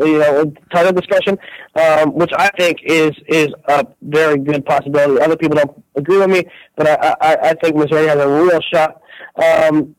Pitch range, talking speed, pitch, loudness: 150-165 Hz, 185 wpm, 155 Hz, -14 LUFS